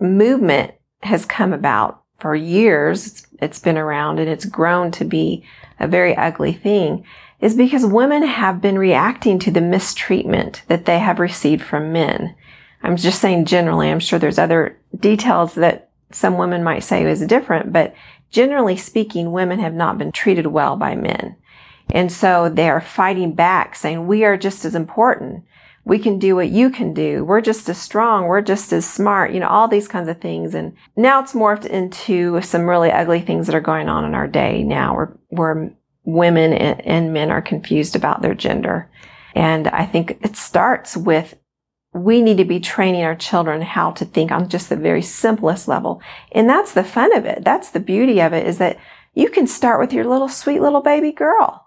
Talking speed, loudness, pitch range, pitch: 195 wpm, -16 LUFS, 165-210 Hz, 180 Hz